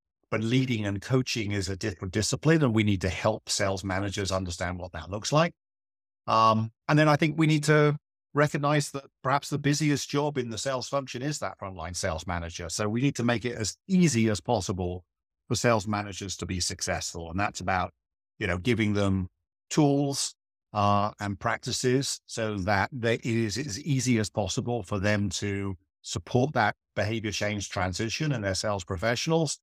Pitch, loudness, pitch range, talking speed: 110 Hz, -28 LUFS, 95-130 Hz, 185 wpm